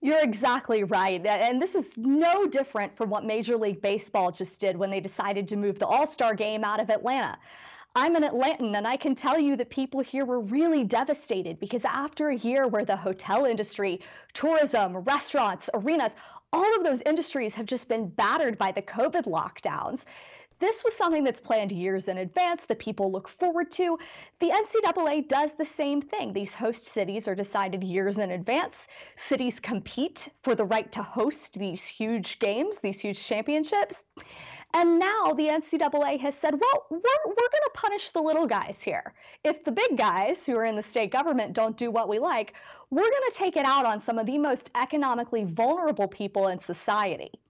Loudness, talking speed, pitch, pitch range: -27 LUFS, 190 wpm, 245 Hz, 210-305 Hz